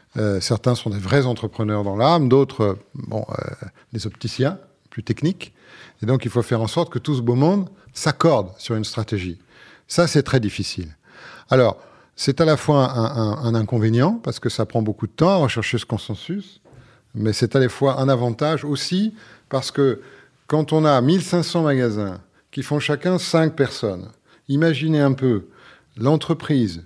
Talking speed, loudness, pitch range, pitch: 180 wpm, -20 LUFS, 110-150 Hz, 130 Hz